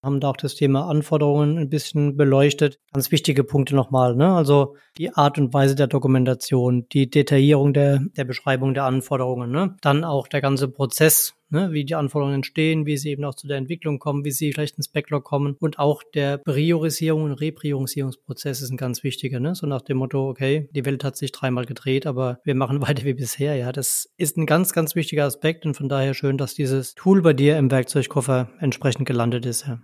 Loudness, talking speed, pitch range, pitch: -21 LUFS, 210 wpm, 135-150 Hz, 140 Hz